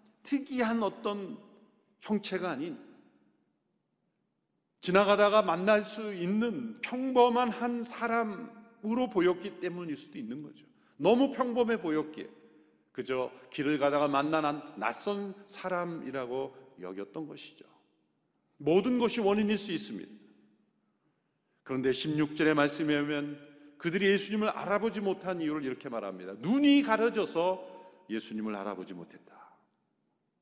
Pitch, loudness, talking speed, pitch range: 190 Hz, -31 LUFS, 260 characters per minute, 145-225 Hz